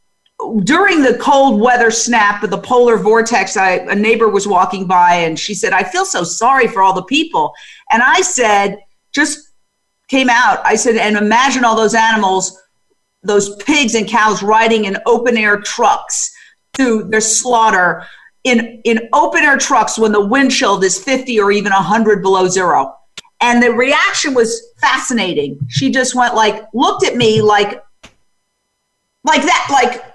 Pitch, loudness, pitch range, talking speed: 225 Hz, -12 LUFS, 205-255 Hz, 165 wpm